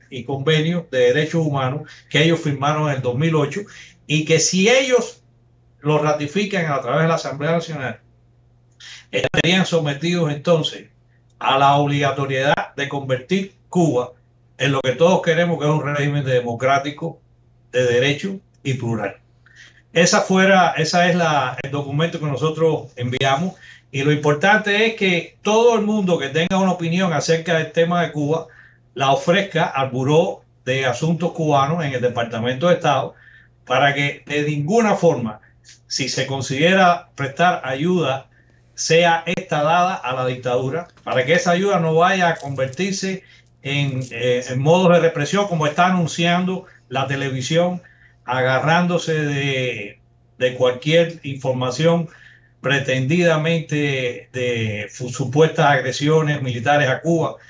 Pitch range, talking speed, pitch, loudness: 130-170 Hz, 140 wpm, 145 Hz, -19 LUFS